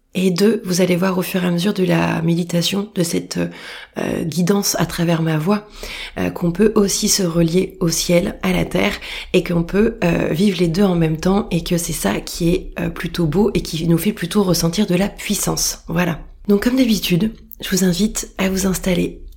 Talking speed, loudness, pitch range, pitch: 215 wpm, -18 LUFS, 170-200 Hz, 180 Hz